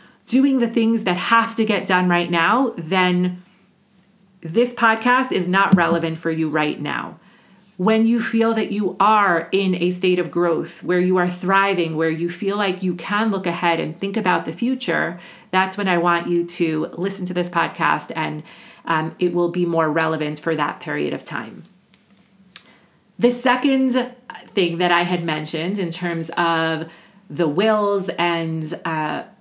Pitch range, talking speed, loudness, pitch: 170-205 Hz, 170 wpm, -20 LUFS, 180 Hz